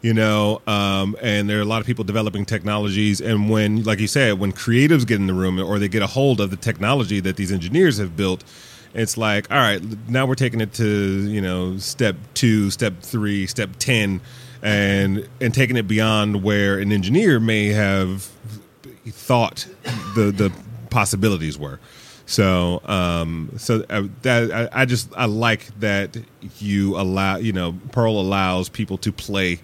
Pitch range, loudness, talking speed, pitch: 100-115 Hz, -20 LUFS, 175 wpm, 105 Hz